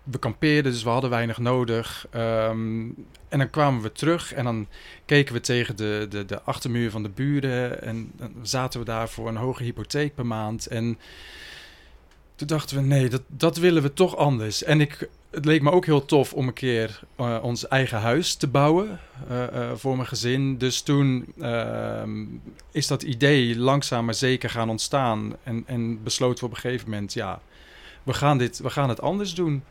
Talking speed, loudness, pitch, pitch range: 195 wpm, -24 LUFS, 125 Hz, 115-140 Hz